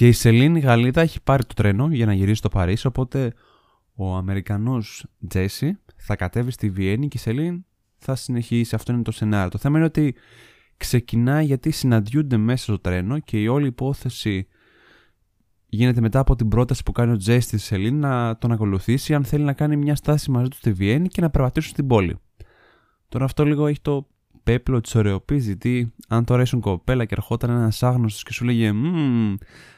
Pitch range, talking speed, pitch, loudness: 105-135 Hz, 185 wpm, 120 Hz, -21 LUFS